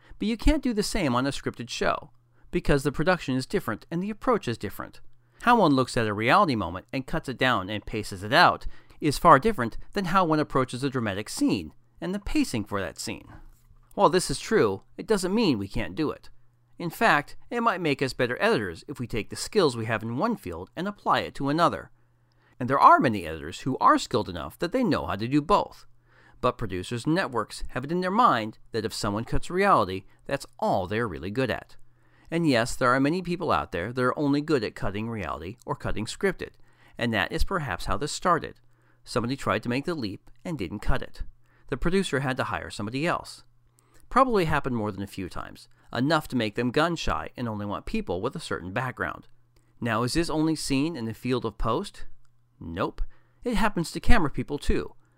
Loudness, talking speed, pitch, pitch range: -26 LUFS, 220 wpm, 125 Hz, 115-160 Hz